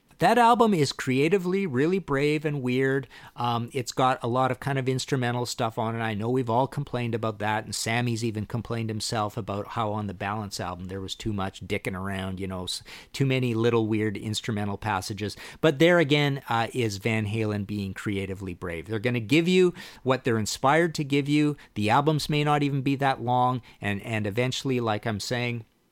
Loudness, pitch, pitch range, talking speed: -26 LUFS, 120 Hz, 105-140 Hz, 200 wpm